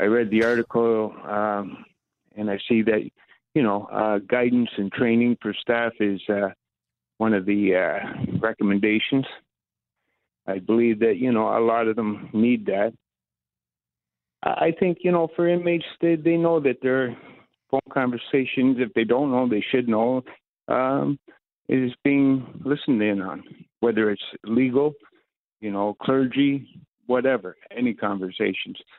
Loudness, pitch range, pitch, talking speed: -23 LUFS, 105-130 Hz, 115 Hz, 145 wpm